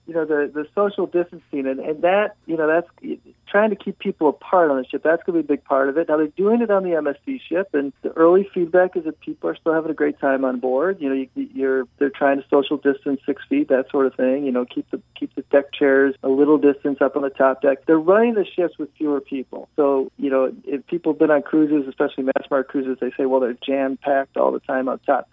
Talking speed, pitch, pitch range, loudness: 270 wpm, 145 Hz, 135-175 Hz, -20 LUFS